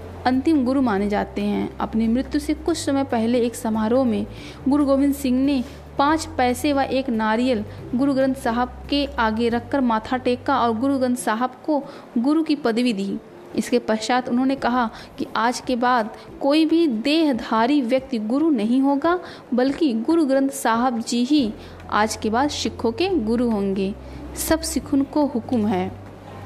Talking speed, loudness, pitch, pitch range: 165 wpm, -21 LUFS, 255 Hz, 235-280 Hz